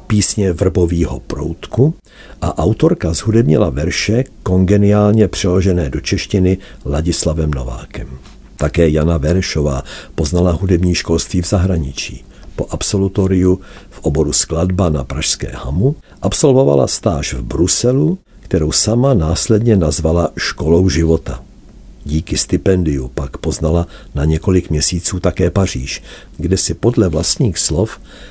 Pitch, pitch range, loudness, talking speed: 90 Hz, 80-100 Hz, -14 LUFS, 110 wpm